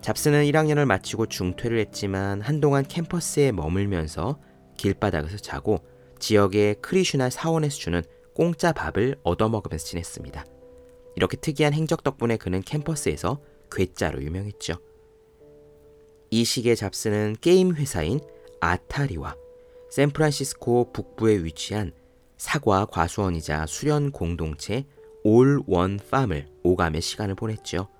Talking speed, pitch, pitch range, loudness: 300 characters per minute, 115 Hz, 95-145 Hz, -24 LUFS